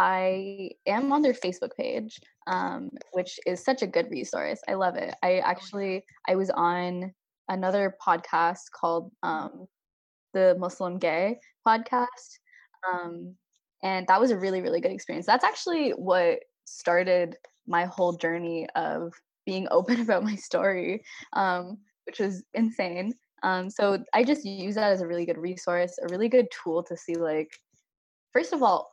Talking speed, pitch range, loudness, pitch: 160 wpm, 180-235 Hz, -27 LUFS, 190 Hz